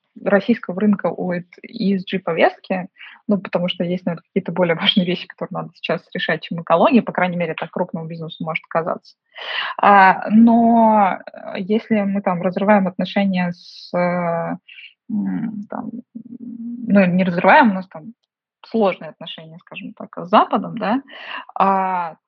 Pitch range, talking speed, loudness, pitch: 180-220 Hz, 135 wpm, -18 LUFS, 195 Hz